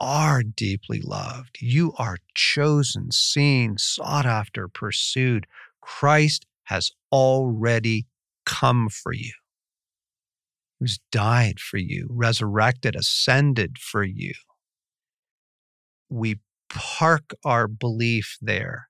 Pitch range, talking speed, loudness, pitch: 110-140 Hz, 90 wpm, -22 LUFS, 125 Hz